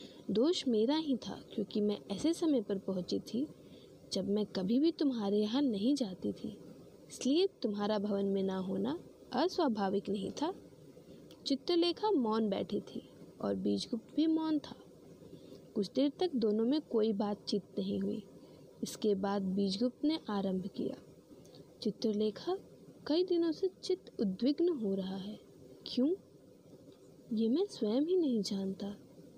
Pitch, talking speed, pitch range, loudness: 225 Hz, 140 wpm, 200-300 Hz, -35 LUFS